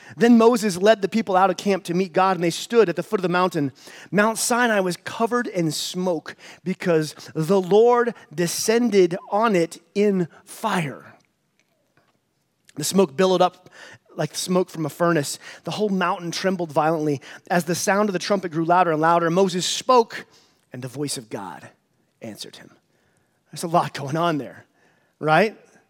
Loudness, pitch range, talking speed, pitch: -21 LUFS, 160-200 Hz, 170 wpm, 180 Hz